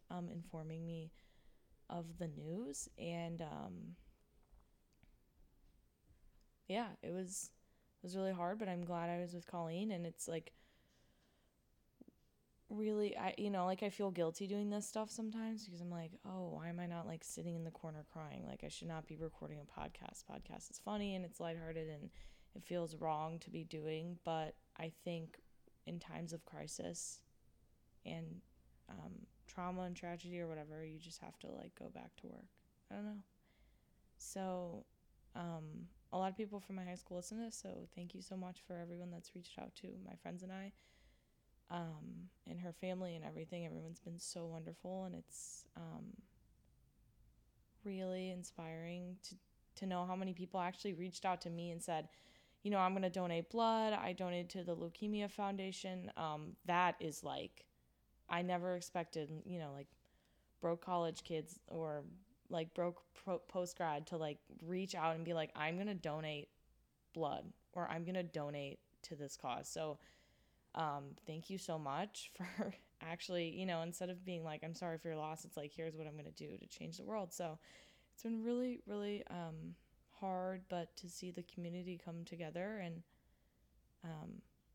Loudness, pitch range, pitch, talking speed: -46 LUFS, 160-185 Hz, 175 Hz, 180 wpm